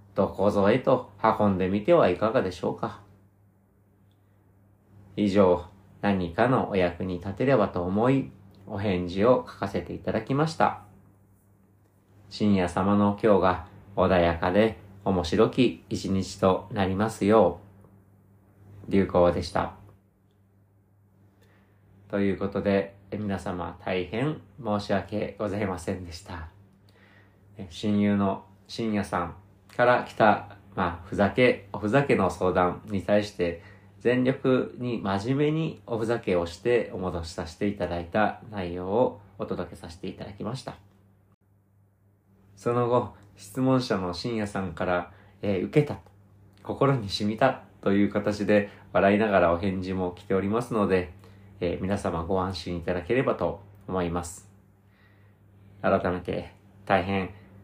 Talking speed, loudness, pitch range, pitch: 245 characters per minute, -26 LUFS, 95-105 Hz, 100 Hz